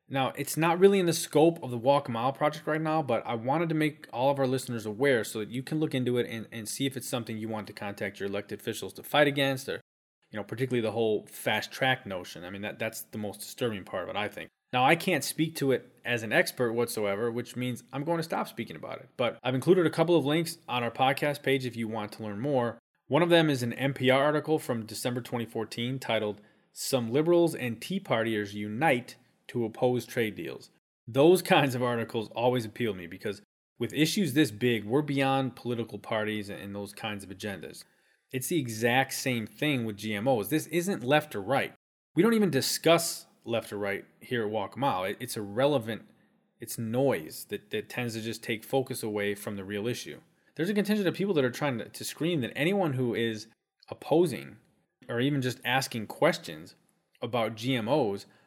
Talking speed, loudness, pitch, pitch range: 215 wpm, -29 LUFS, 125 Hz, 110-150 Hz